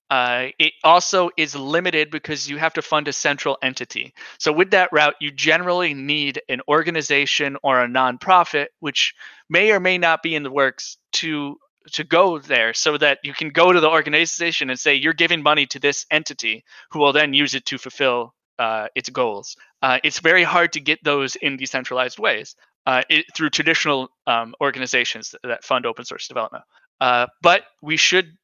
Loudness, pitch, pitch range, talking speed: -18 LUFS, 150 Hz, 135-160 Hz, 190 wpm